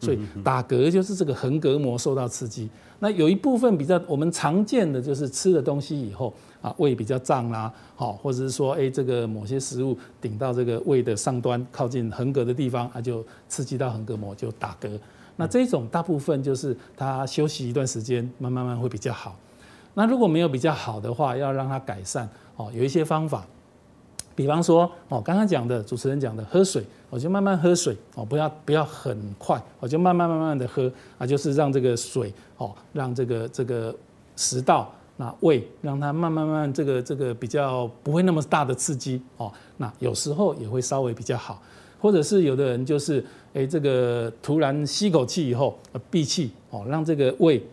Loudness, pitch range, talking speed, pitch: -25 LUFS, 120-155 Hz, 295 characters per minute, 135 Hz